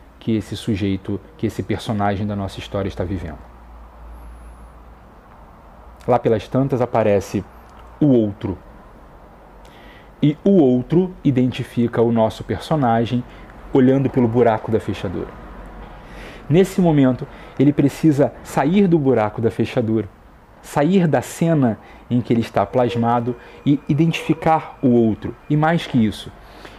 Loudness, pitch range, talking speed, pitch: -19 LUFS, 100-135 Hz, 120 wpm, 115 Hz